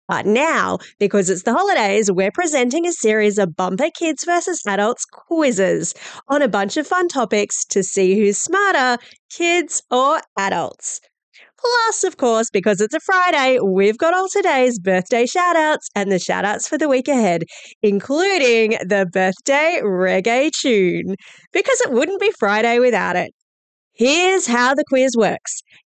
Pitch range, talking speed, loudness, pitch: 205-325 Hz, 155 wpm, -17 LUFS, 245 Hz